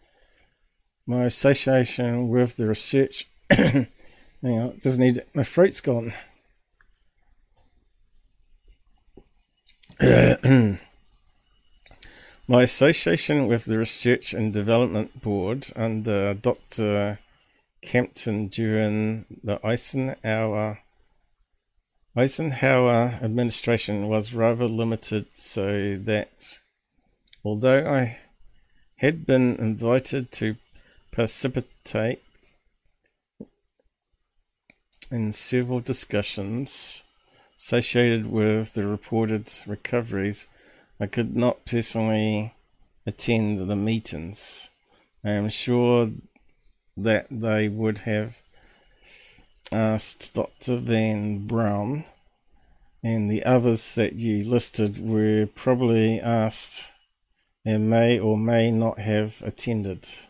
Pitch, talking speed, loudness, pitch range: 115 Hz, 80 wpm, -23 LUFS, 105-125 Hz